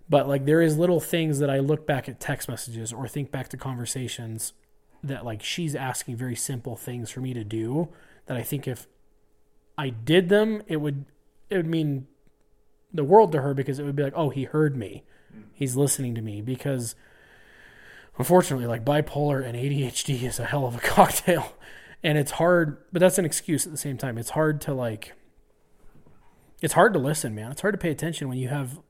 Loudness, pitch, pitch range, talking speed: -25 LUFS, 140 Hz, 125-155 Hz, 205 wpm